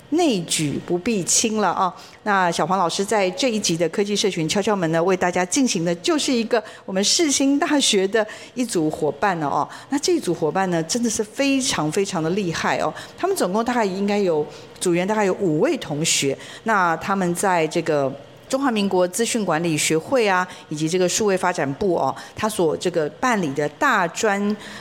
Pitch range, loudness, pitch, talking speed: 165-225 Hz, -21 LUFS, 190 Hz, 290 characters per minute